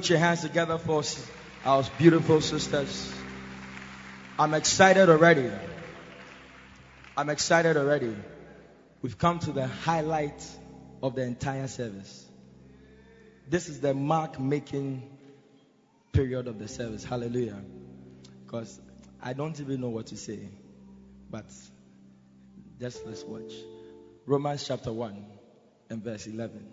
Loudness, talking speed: -27 LUFS, 115 wpm